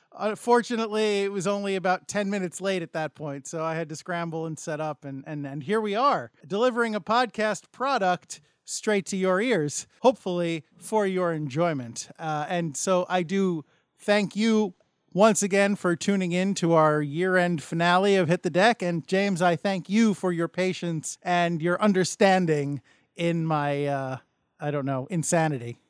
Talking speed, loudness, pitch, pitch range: 175 wpm, -25 LUFS, 180 Hz, 160-200 Hz